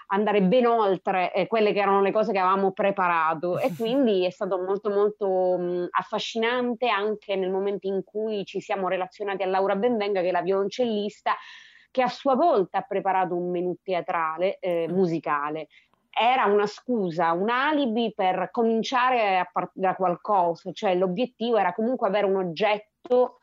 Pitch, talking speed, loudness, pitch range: 195 Hz, 165 wpm, -25 LUFS, 185-220 Hz